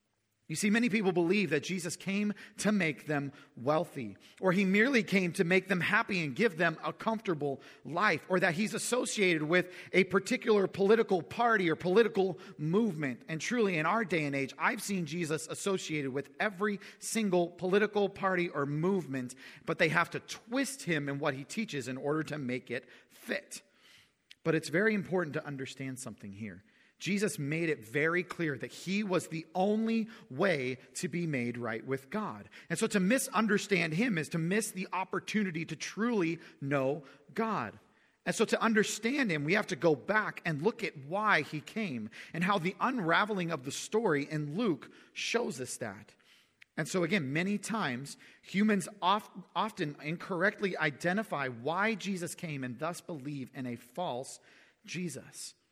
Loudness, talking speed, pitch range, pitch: -32 LUFS, 170 wpm, 150-210 Hz, 180 Hz